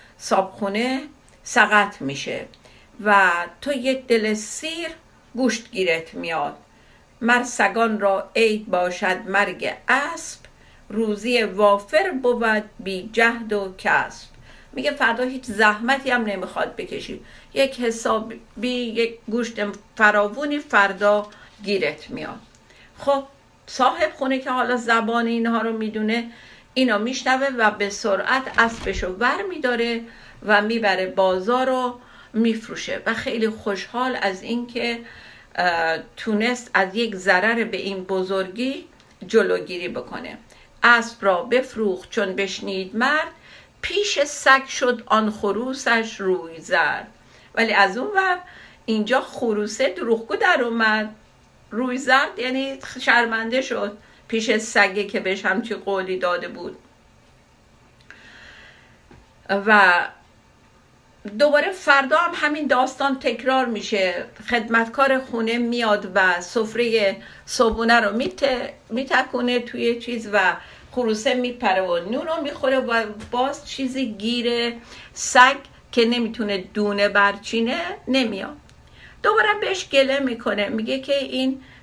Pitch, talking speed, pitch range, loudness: 230 Hz, 115 wpm, 205-255 Hz, -21 LUFS